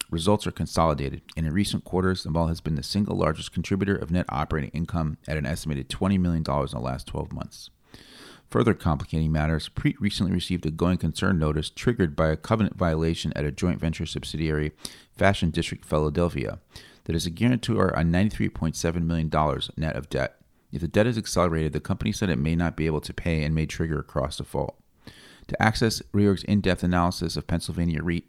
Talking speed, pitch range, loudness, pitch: 195 wpm, 75-95 Hz, -26 LUFS, 85 Hz